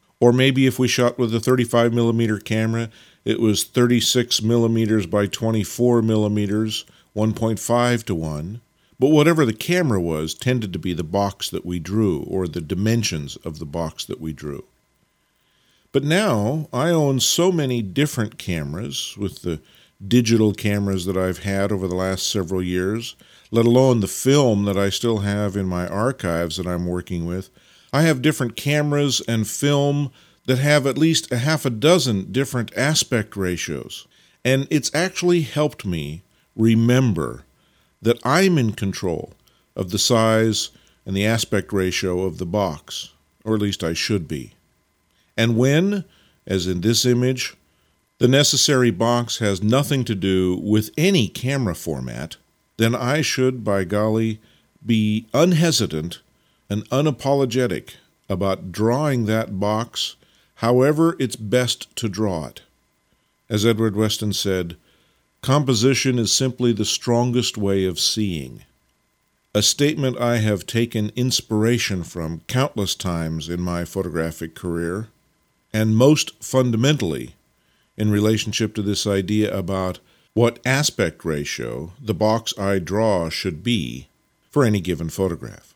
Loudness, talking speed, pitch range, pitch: -20 LUFS, 145 wpm, 95-125 Hz, 110 Hz